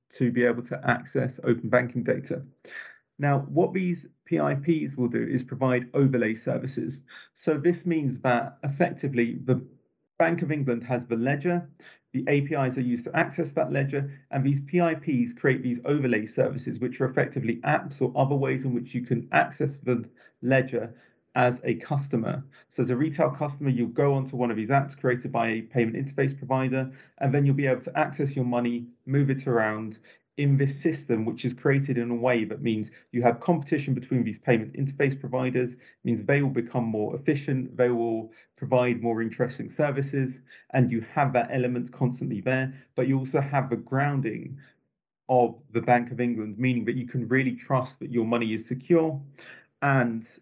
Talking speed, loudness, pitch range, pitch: 180 wpm, -27 LUFS, 120-140 Hz, 130 Hz